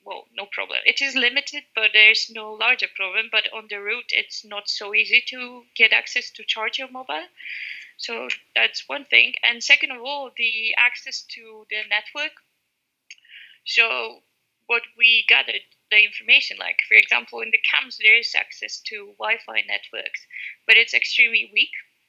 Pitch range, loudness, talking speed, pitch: 215-265 Hz, -18 LUFS, 170 wpm, 230 Hz